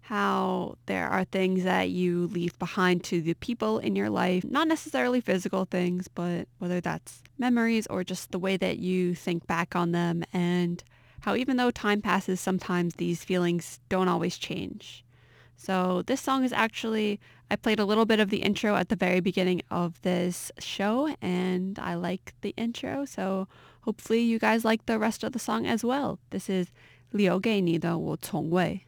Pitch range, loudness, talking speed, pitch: 175-220 Hz, -28 LUFS, 180 wpm, 185 Hz